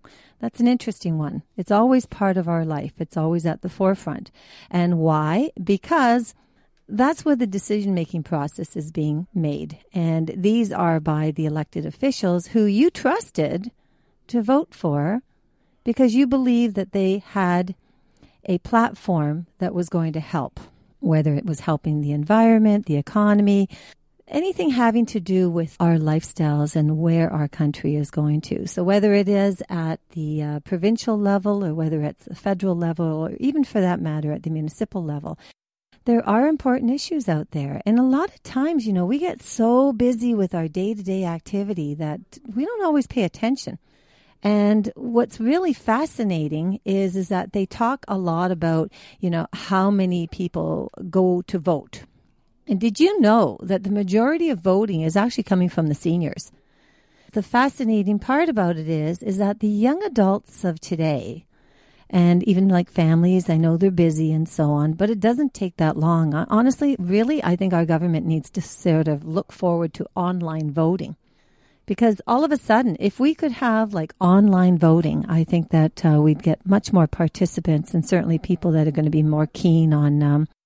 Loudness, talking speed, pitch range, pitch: -21 LUFS, 180 wpm, 160-220 Hz, 185 Hz